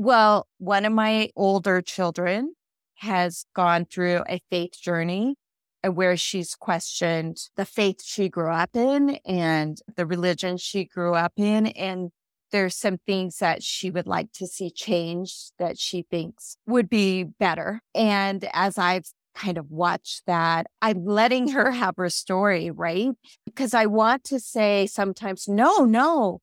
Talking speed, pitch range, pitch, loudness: 150 wpm, 175-220 Hz, 190 Hz, -24 LUFS